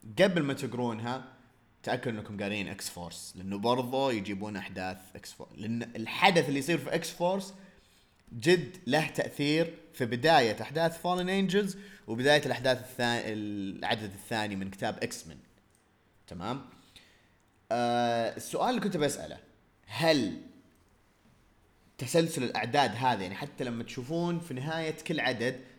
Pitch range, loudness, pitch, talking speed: 105-155 Hz, -31 LUFS, 125 Hz, 130 wpm